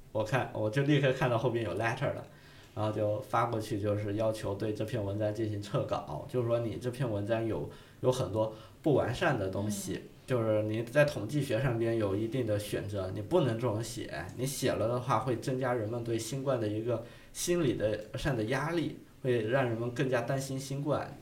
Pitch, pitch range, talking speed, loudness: 120 Hz, 110-135 Hz, 310 characters per minute, -32 LUFS